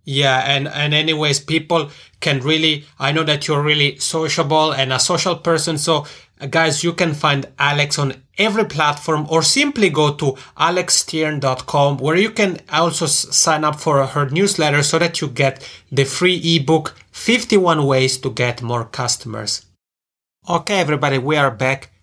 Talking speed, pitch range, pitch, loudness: 160 wpm, 140-165 Hz, 150 Hz, -17 LUFS